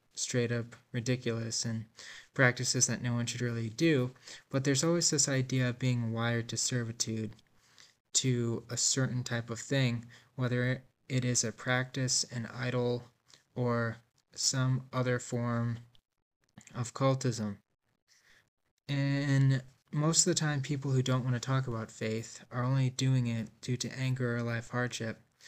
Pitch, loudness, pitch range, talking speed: 125 Hz, -32 LUFS, 115-130 Hz, 150 wpm